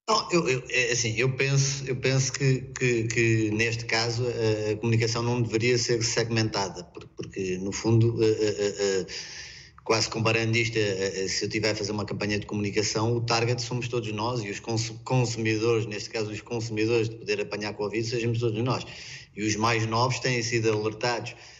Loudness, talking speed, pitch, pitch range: -26 LUFS, 185 wpm, 115 Hz, 110-120 Hz